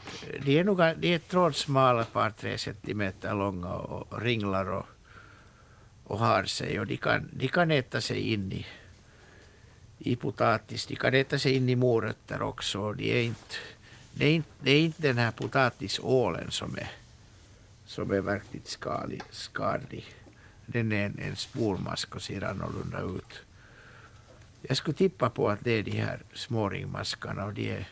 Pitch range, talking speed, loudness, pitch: 105-135 Hz, 160 wpm, -29 LUFS, 115 Hz